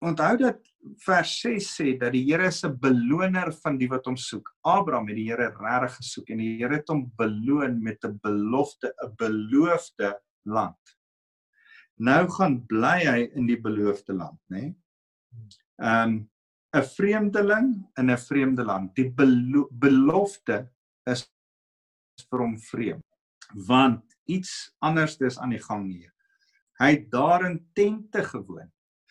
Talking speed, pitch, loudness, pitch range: 140 wpm, 130 Hz, -25 LUFS, 115-170 Hz